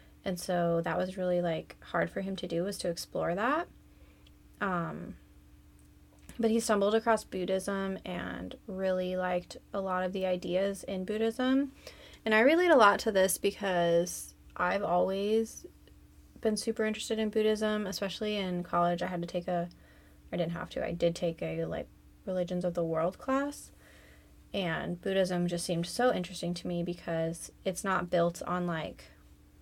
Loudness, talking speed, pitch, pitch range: -31 LUFS, 165 wpm, 180 Hz, 165-200 Hz